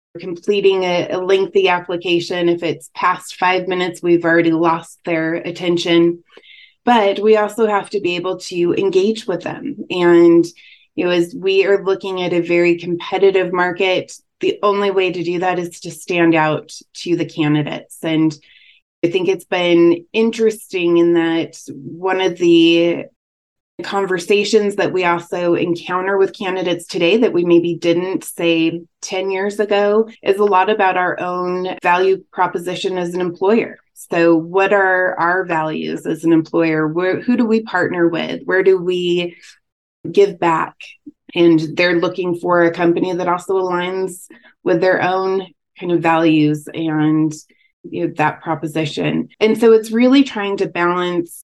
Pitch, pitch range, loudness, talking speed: 180 Hz, 170-195 Hz, -16 LUFS, 155 wpm